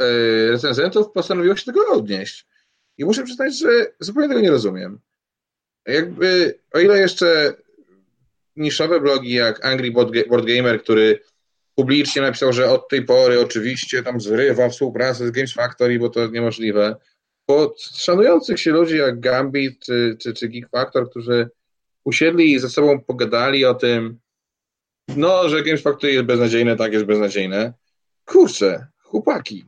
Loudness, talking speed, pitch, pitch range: -17 LUFS, 150 wpm, 130 Hz, 120-170 Hz